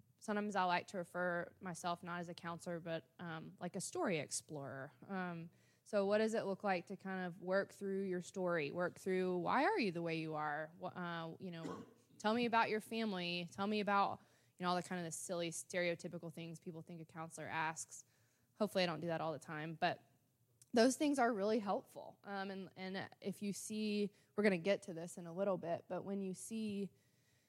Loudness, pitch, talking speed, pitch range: -41 LUFS, 180 Hz, 215 wpm, 165-195 Hz